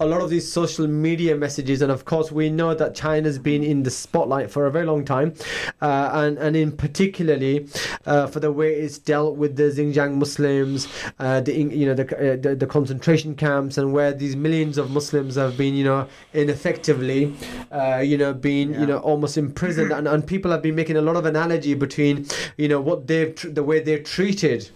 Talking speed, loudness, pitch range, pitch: 215 wpm, -21 LUFS, 140-155 Hz, 150 Hz